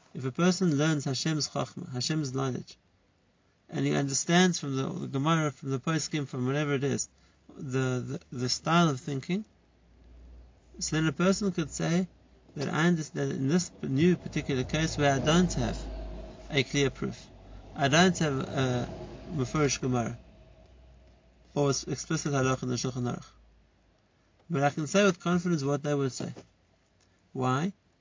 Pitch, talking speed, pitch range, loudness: 140 Hz, 160 wpm, 125-160 Hz, -29 LUFS